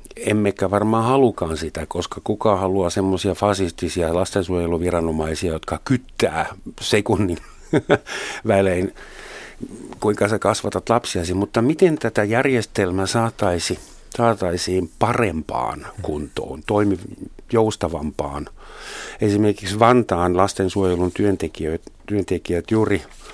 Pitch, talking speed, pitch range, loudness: 100 Hz, 85 wpm, 90-110 Hz, -21 LUFS